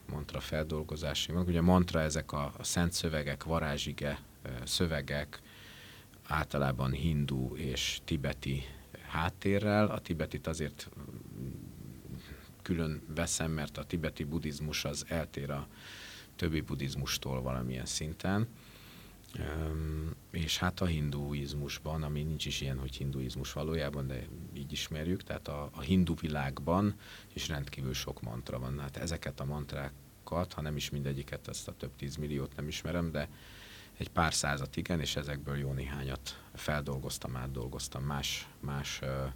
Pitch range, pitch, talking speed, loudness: 70-85 Hz, 75 Hz, 135 wpm, -36 LUFS